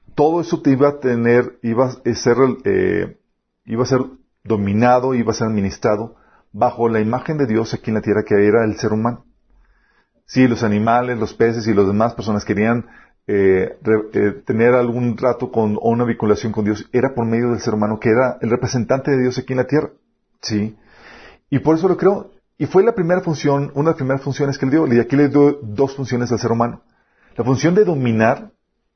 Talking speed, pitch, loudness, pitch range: 215 wpm, 120 Hz, -17 LUFS, 110-135 Hz